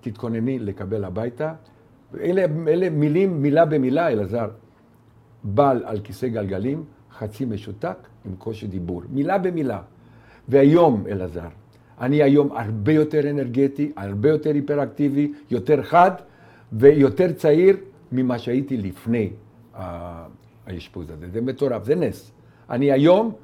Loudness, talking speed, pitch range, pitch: -21 LUFS, 115 wpm, 110-145 Hz, 125 Hz